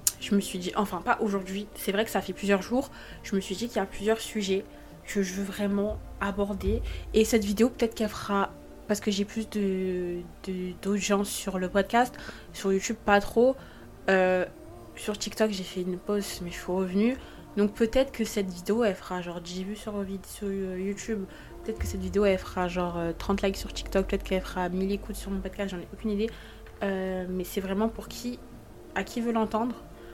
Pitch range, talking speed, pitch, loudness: 185-215 Hz, 205 wpm, 200 Hz, -29 LUFS